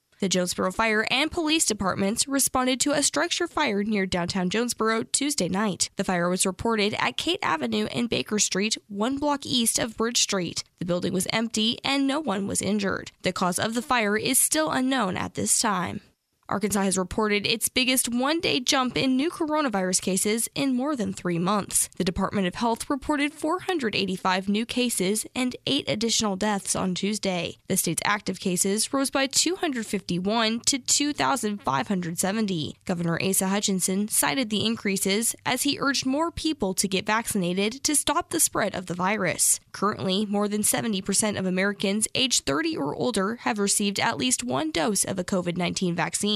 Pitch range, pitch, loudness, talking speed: 190-260 Hz, 215 Hz, -24 LUFS, 170 wpm